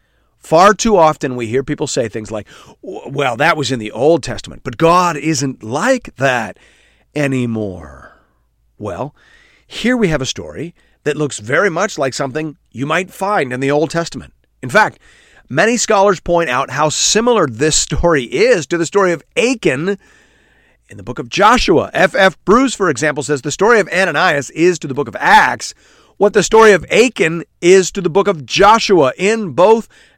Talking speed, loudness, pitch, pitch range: 180 wpm, -13 LUFS, 165 Hz, 140-200 Hz